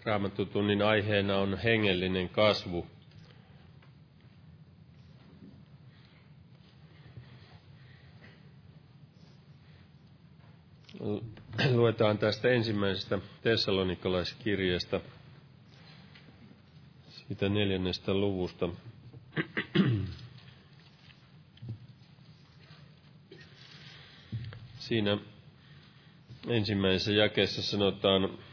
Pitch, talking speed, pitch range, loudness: 120 Hz, 35 wpm, 105-145 Hz, -30 LUFS